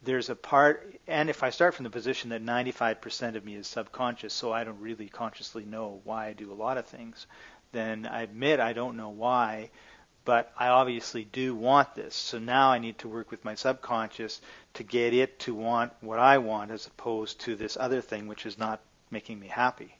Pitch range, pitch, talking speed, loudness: 110-125 Hz, 115 Hz, 215 wpm, -29 LUFS